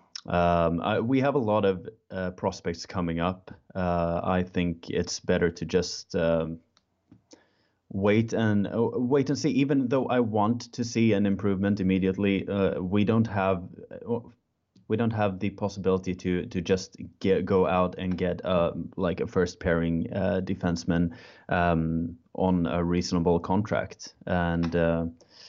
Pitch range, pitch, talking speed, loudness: 85-105 Hz, 95 Hz, 155 wpm, -27 LUFS